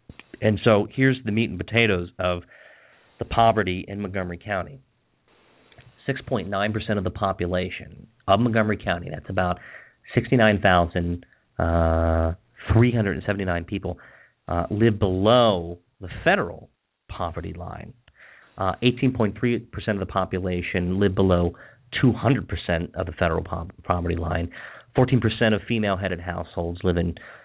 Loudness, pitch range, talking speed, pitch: -23 LUFS, 90-110 Hz, 125 wpm, 95 Hz